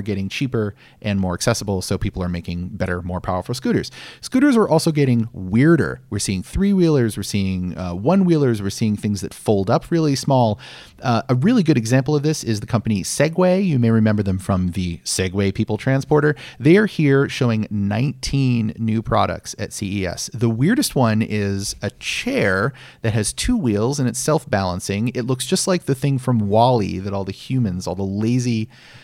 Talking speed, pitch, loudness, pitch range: 190 wpm, 115 Hz, -20 LUFS, 100-135 Hz